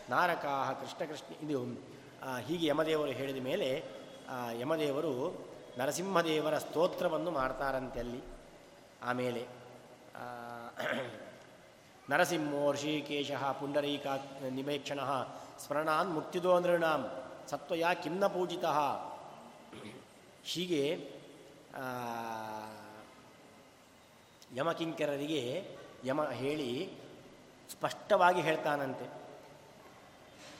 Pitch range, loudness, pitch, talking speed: 125-155 Hz, -35 LUFS, 145 Hz, 60 wpm